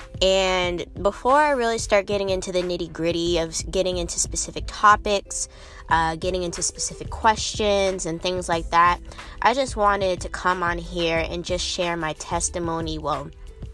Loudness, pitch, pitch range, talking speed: -23 LUFS, 180 Hz, 165-195 Hz, 160 wpm